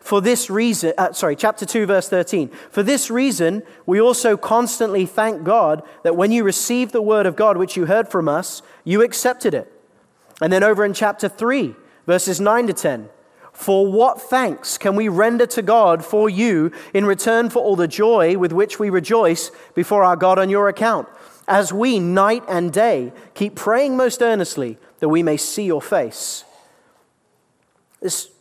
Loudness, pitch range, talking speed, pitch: -18 LUFS, 185-230 Hz, 180 wpm, 205 Hz